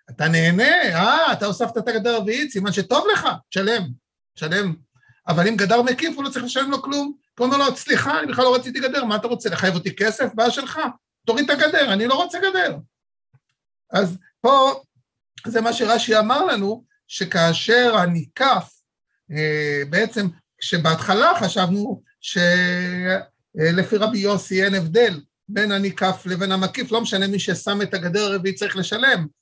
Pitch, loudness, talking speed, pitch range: 205 Hz, -20 LUFS, 155 wpm, 180-245 Hz